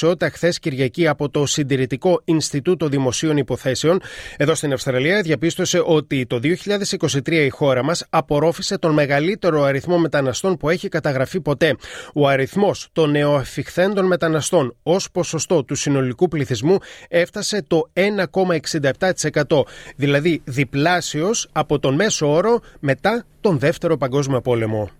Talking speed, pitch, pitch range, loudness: 125 wpm, 155 Hz, 140-175 Hz, -19 LUFS